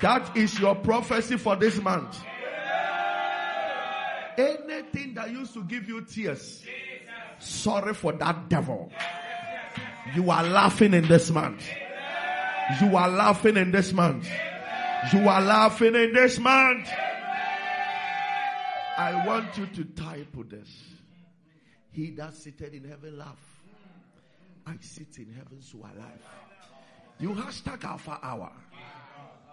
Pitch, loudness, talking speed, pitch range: 195 Hz, -25 LUFS, 130 wpm, 155-230 Hz